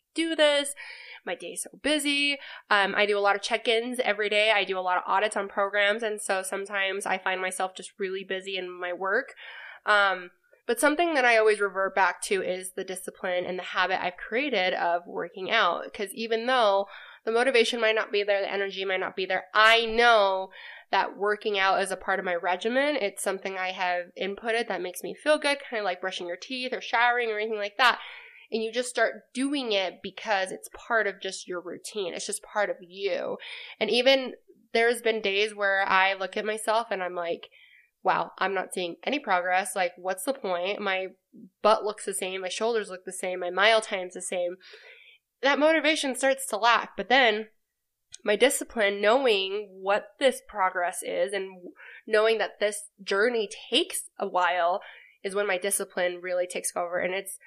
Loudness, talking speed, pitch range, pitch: -26 LUFS, 200 wpm, 190-235 Hz, 205 Hz